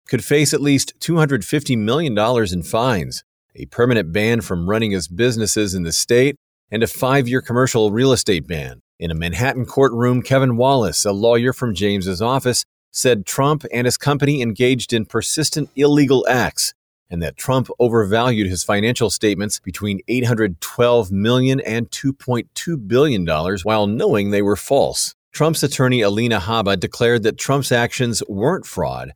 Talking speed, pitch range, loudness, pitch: 150 wpm, 105-130 Hz, -18 LUFS, 120 Hz